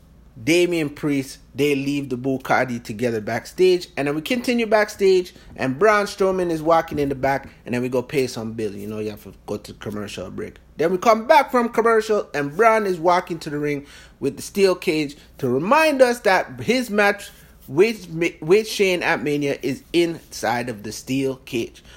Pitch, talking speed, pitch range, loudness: 155 Hz, 195 wpm, 130-200 Hz, -21 LUFS